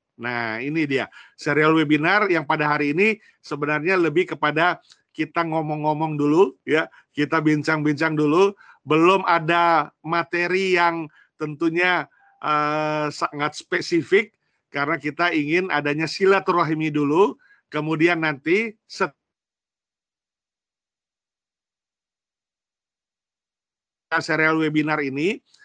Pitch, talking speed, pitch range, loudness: 160 Hz, 90 wpm, 150-170 Hz, -21 LUFS